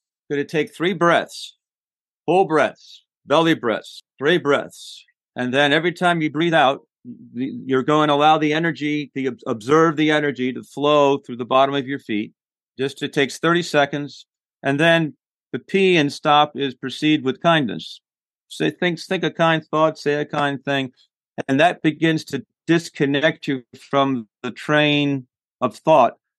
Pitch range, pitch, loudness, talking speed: 135-160 Hz, 150 Hz, -19 LUFS, 165 wpm